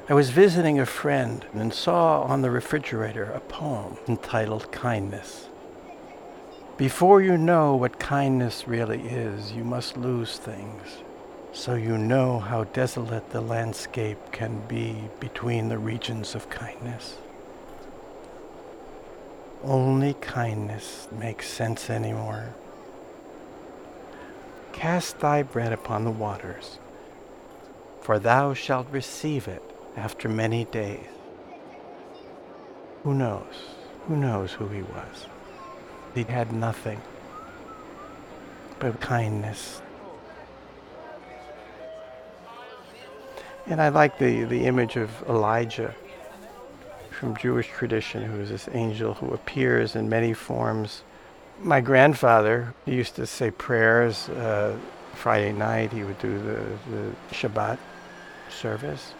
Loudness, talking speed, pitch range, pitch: -25 LUFS, 110 wpm, 110-135 Hz, 115 Hz